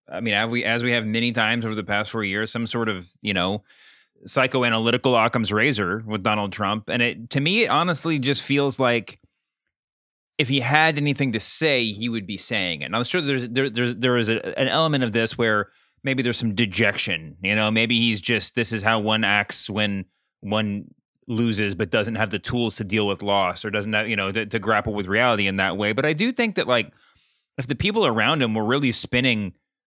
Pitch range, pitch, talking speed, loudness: 105-125 Hz, 115 Hz, 225 wpm, -22 LUFS